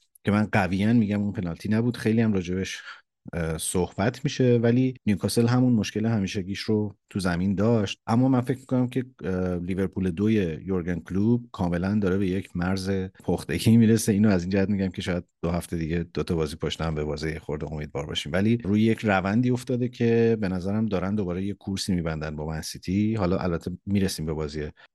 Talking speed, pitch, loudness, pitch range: 190 wpm, 100 Hz, -25 LUFS, 90-110 Hz